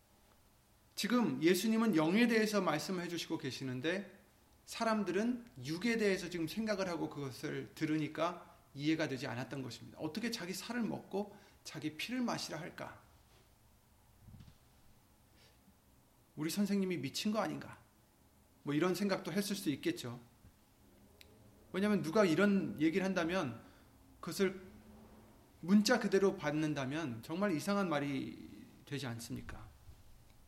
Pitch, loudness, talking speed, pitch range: 170 Hz, -36 LUFS, 270 characters per minute, 135-200 Hz